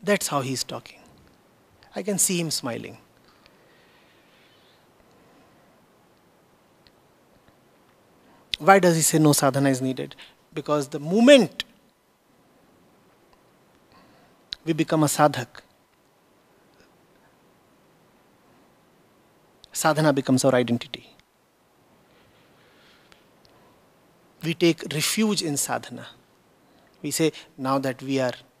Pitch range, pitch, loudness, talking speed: 135-165 Hz, 150 Hz, -22 LUFS, 80 wpm